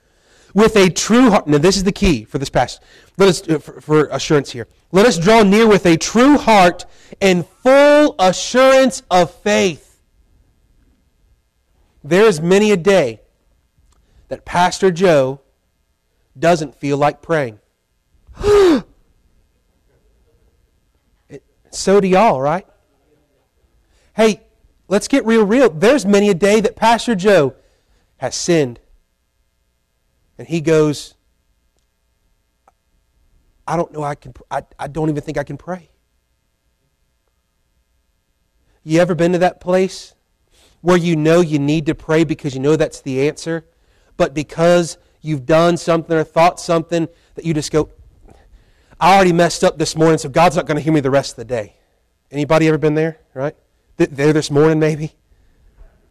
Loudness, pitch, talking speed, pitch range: -15 LUFS, 160 Hz, 145 wpm, 130-185 Hz